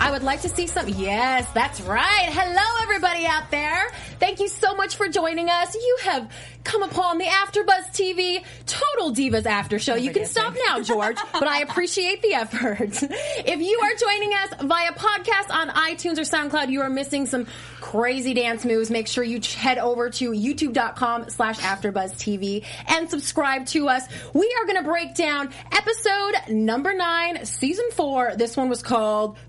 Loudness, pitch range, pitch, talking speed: -22 LUFS, 245-385 Hz, 315 Hz, 175 wpm